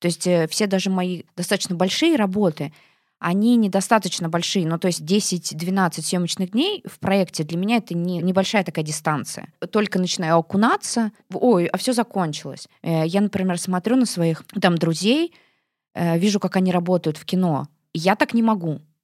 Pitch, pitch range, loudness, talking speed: 185 Hz, 170-205 Hz, -21 LUFS, 160 wpm